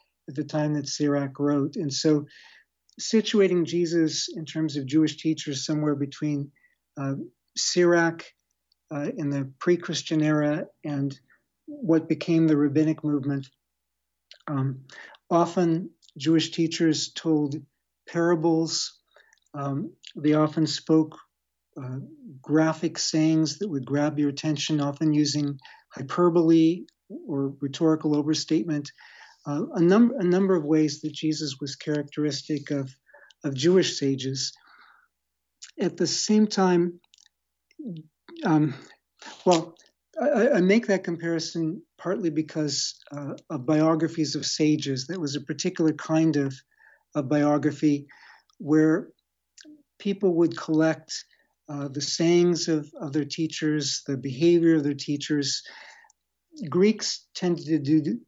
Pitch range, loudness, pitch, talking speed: 145-170 Hz, -25 LUFS, 155 Hz, 120 wpm